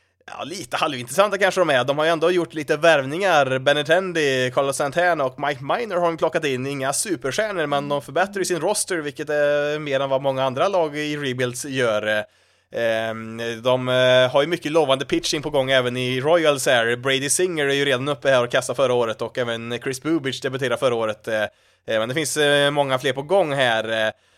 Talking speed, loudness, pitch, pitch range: 195 wpm, -21 LUFS, 140 Hz, 130-160 Hz